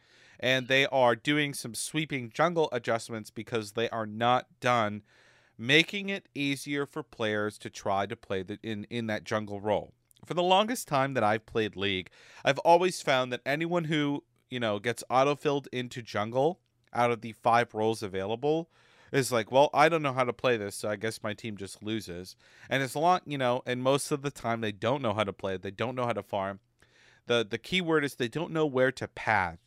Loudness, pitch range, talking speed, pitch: -29 LUFS, 110-140 Hz, 215 wpm, 120 Hz